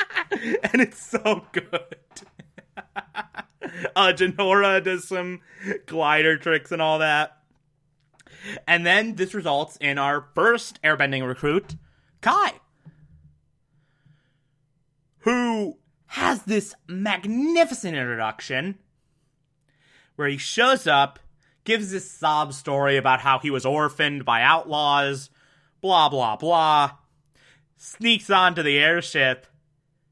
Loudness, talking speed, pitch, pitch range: -22 LUFS, 100 wpm, 155 Hz, 140-190 Hz